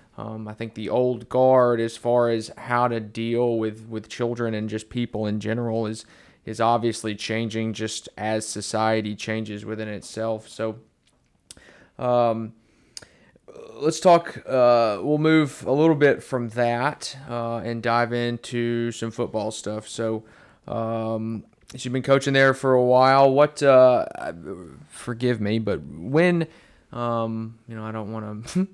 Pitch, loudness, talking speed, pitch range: 115 Hz, -23 LUFS, 150 wpm, 110-125 Hz